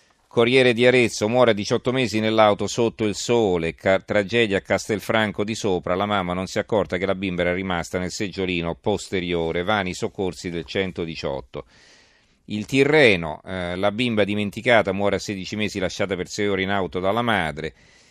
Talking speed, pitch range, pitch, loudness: 170 wpm, 90-110 Hz, 100 Hz, -22 LUFS